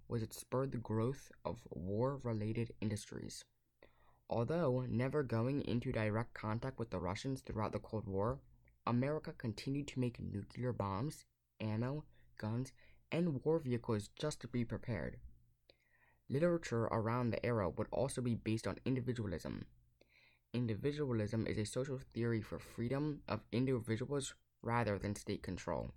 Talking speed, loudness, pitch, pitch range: 140 wpm, -40 LUFS, 115 Hz, 105-130 Hz